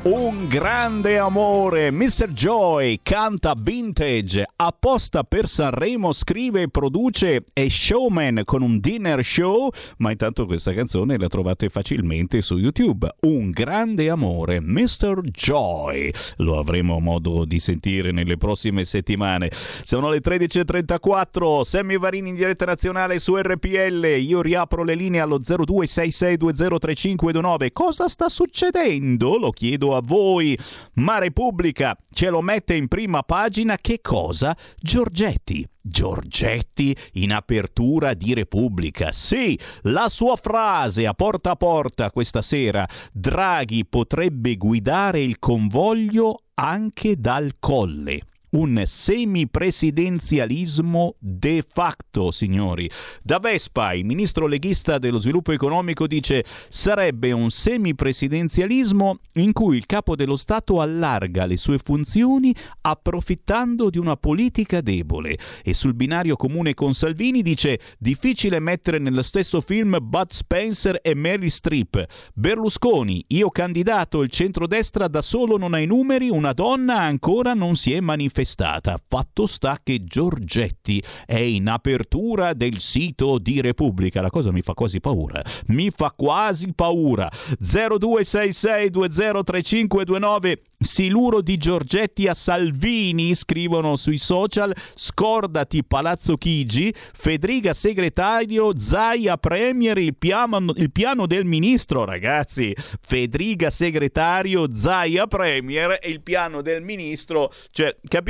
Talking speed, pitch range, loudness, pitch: 120 wpm, 125-195 Hz, -21 LUFS, 165 Hz